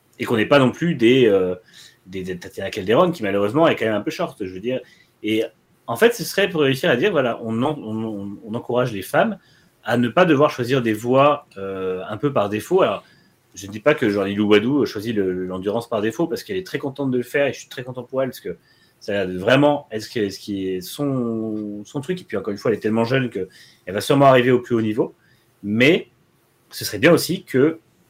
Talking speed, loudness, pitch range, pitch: 240 wpm, -20 LUFS, 105-140 Hz, 120 Hz